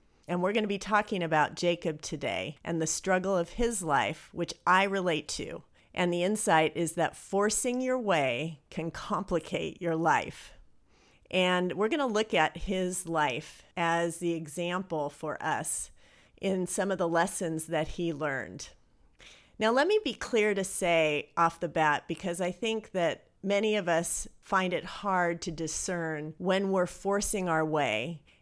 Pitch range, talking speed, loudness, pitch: 160-195 Hz, 165 wpm, -30 LUFS, 175 Hz